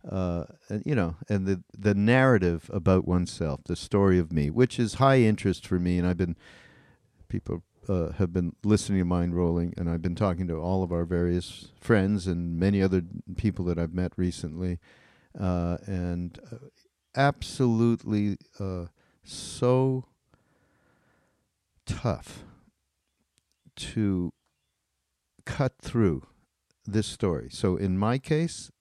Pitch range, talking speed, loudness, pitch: 85-110 Hz, 135 wpm, -27 LUFS, 95 Hz